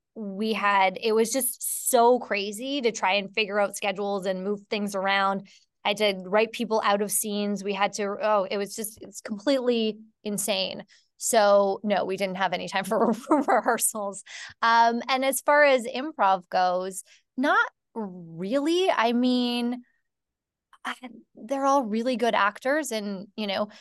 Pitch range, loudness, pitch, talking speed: 200-240 Hz, -25 LUFS, 215 Hz, 160 wpm